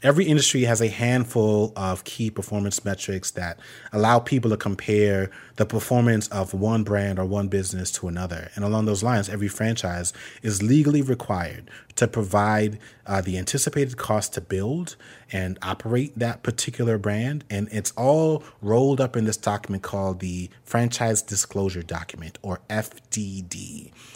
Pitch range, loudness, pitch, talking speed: 95-120 Hz, -24 LUFS, 105 Hz, 150 wpm